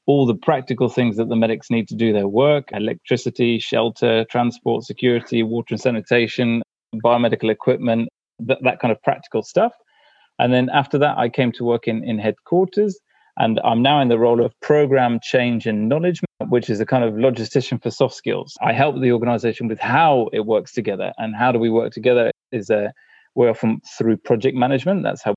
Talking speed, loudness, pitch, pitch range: 195 wpm, -19 LUFS, 120 Hz, 115-135 Hz